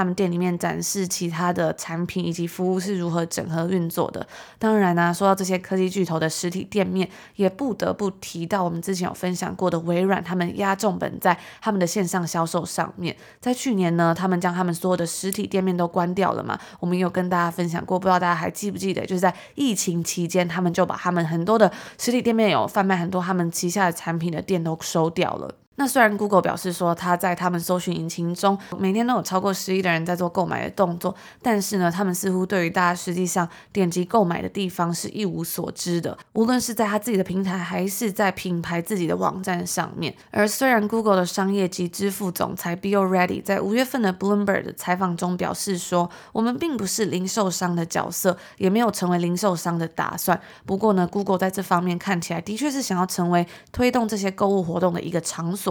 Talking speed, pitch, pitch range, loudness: 370 characters per minute, 185 Hz, 175-200 Hz, -23 LUFS